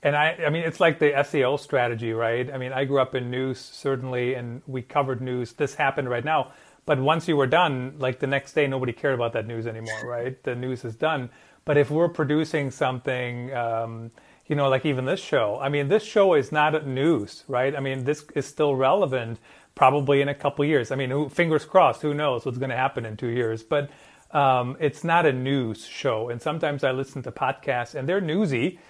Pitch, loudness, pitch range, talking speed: 135 Hz, -24 LUFS, 125-150 Hz, 225 wpm